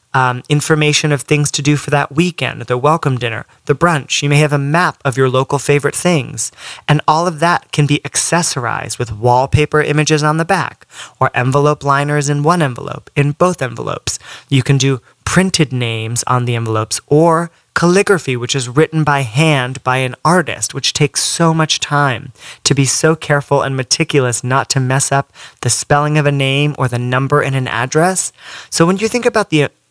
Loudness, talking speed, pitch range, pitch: -14 LUFS, 195 wpm, 130-155 Hz, 145 Hz